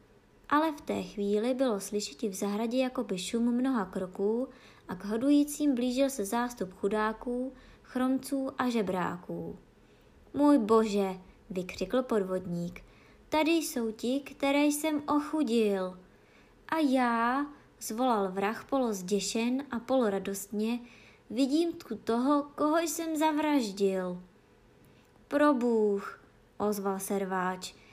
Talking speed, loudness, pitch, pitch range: 105 wpm, -30 LUFS, 235 Hz, 200-275 Hz